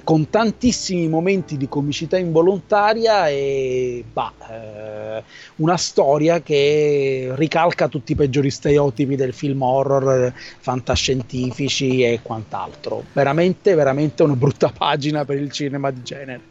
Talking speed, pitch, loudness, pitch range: 120 wpm, 145 Hz, -19 LUFS, 130-160 Hz